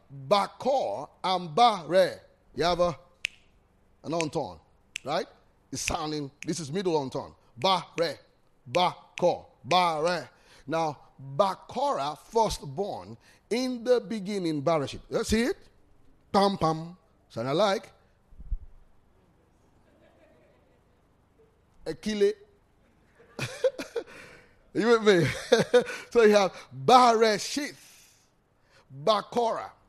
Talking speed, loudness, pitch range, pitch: 85 wpm, -27 LUFS, 140-230 Hz, 180 Hz